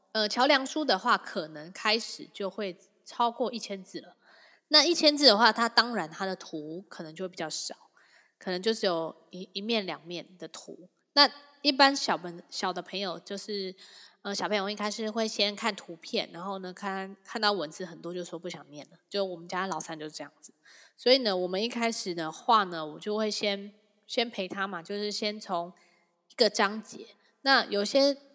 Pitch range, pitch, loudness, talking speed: 180-225 Hz, 200 Hz, -28 LUFS, 275 characters per minute